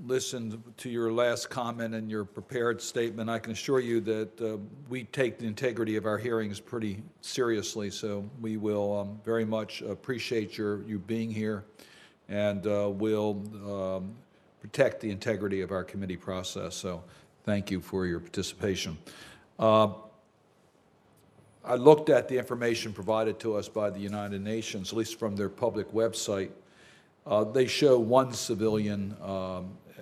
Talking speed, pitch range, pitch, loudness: 155 wpm, 100-115 Hz, 110 Hz, -30 LUFS